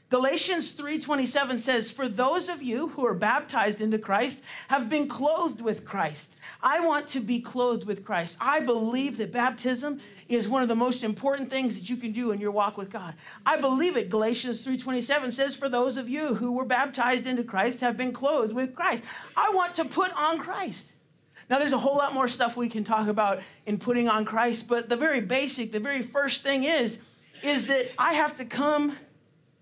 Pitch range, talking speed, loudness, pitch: 225-280 Hz, 205 wpm, -27 LUFS, 250 Hz